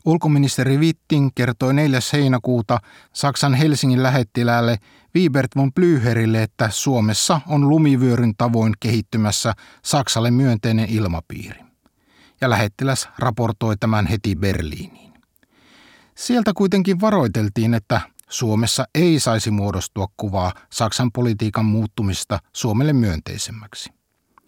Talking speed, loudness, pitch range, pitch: 100 wpm, -19 LUFS, 110-135 Hz, 120 Hz